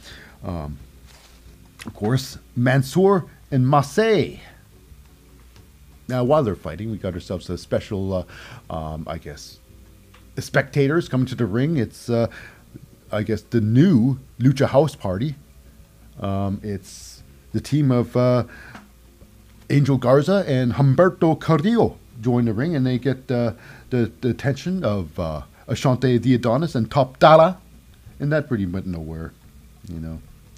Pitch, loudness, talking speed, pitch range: 115 Hz, -21 LUFS, 135 wpm, 90-135 Hz